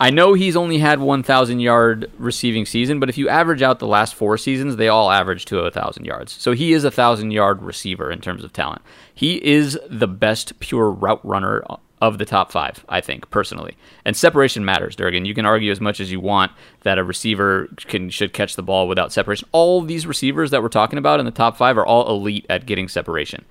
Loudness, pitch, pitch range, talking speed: -18 LUFS, 110 Hz, 100-135 Hz, 230 wpm